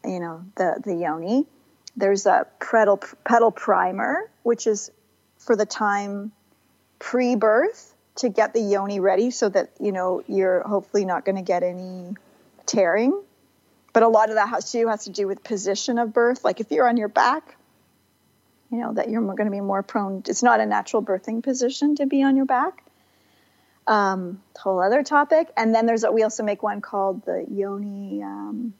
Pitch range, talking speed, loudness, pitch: 195-240 Hz, 185 wpm, -22 LUFS, 215 Hz